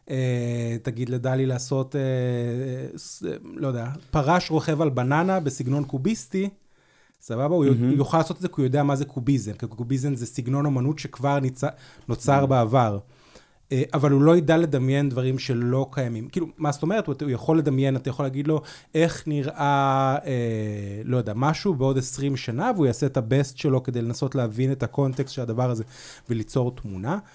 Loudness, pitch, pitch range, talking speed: -24 LUFS, 135 Hz, 125-145 Hz, 160 wpm